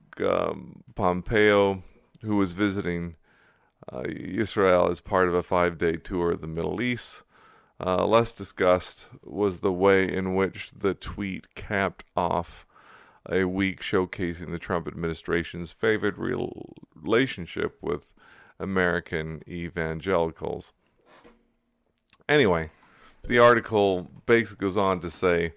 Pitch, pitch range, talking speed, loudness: 90 Hz, 85-100 Hz, 115 wpm, -26 LUFS